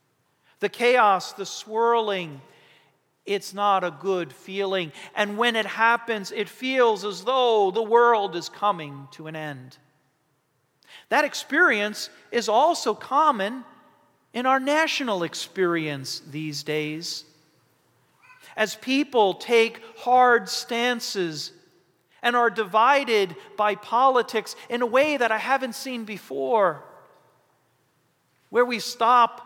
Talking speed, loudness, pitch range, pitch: 115 wpm, -23 LUFS, 170-245 Hz, 215 Hz